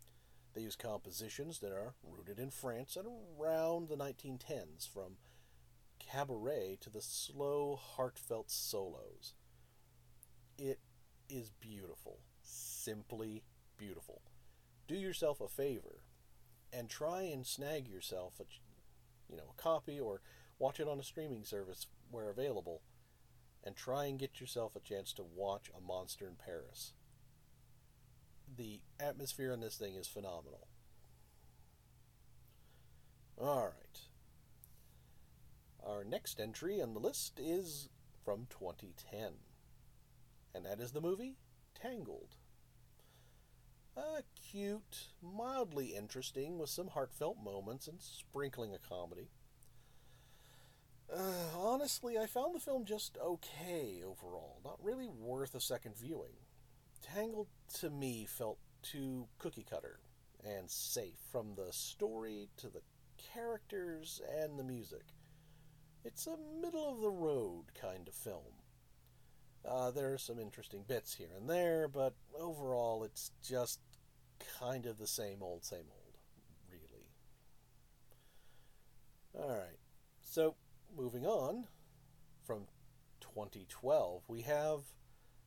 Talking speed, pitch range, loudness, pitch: 120 wpm, 110-150 Hz, -44 LUFS, 130 Hz